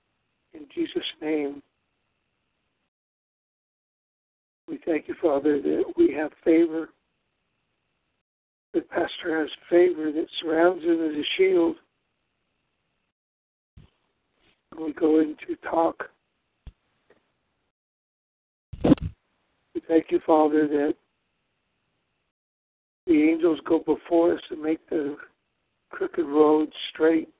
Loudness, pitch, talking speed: -24 LUFS, 160 Hz, 90 wpm